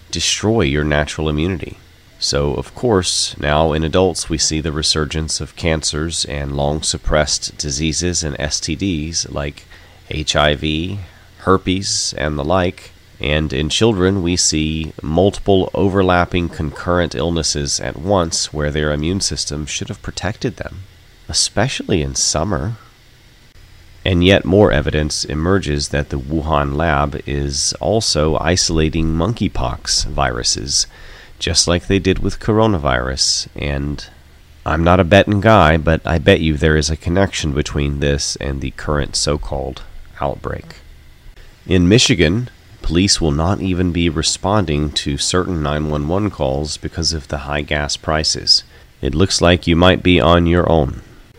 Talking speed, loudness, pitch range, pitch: 140 wpm, -16 LUFS, 75-95 Hz, 80 Hz